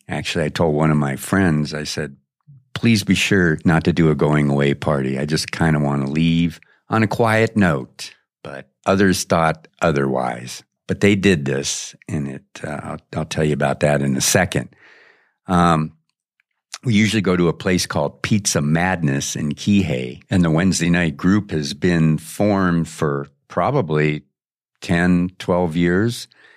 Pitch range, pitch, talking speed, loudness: 75-95 Hz, 80 Hz, 170 wpm, -19 LUFS